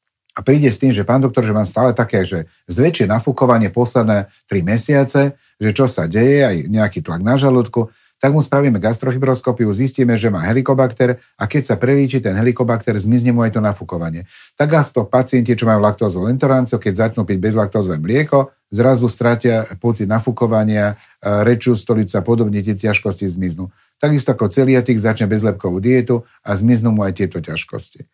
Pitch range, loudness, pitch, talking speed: 105-130 Hz, -16 LUFS, 115 Hz, 175 wpm